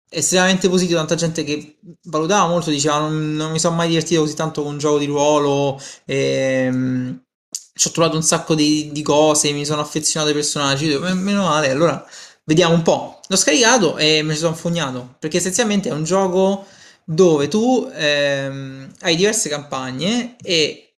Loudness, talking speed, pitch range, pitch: -17 LUFS, 175 wpm, 150-185 Hz, 155 Hz